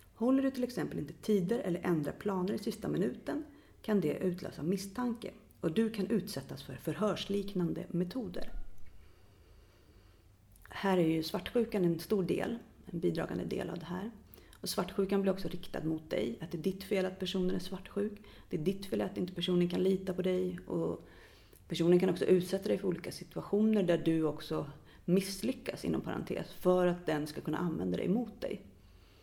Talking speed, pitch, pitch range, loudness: 180 wpm, 185 Hz, 160-200 Hz, -34 LUFS